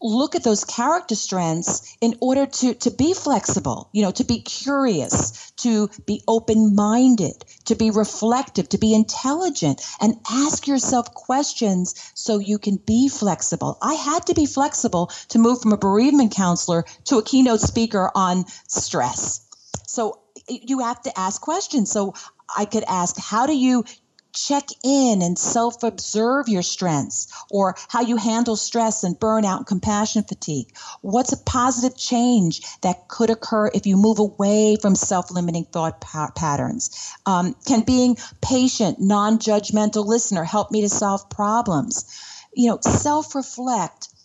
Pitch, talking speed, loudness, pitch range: 220 Hz, 155 wpm, -20 LUFS, 200-250 Hz